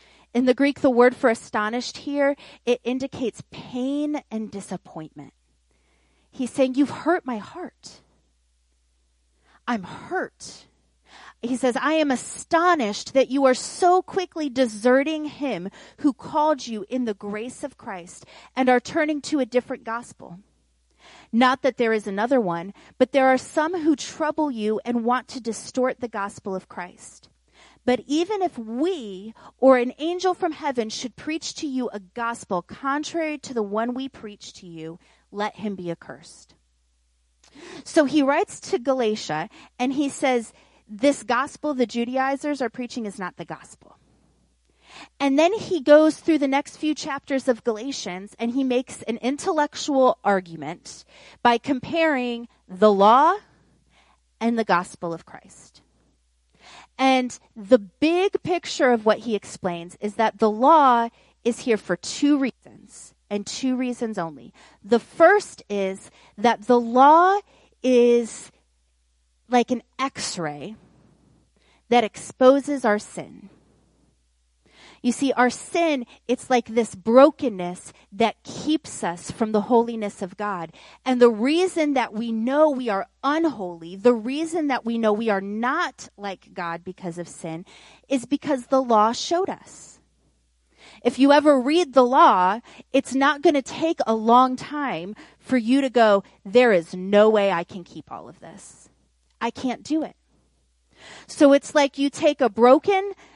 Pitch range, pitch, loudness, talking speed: 200-280 Hz, 245 Hz, -22 LUFS, 150 wpm